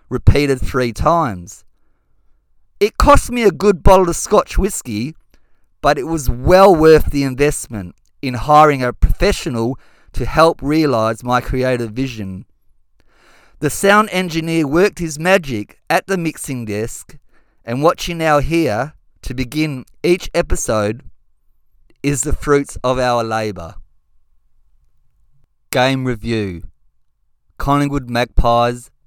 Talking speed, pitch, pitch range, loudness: 120 wpm, 130 Hz, 110-160 Hz, -16 LUFS